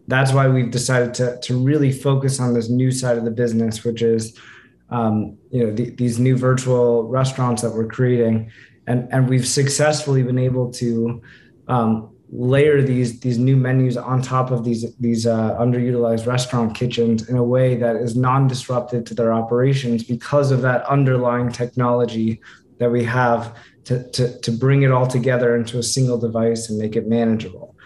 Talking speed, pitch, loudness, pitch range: 180 wpm, 120 Hz, -19 LUFS, 115-130 Hz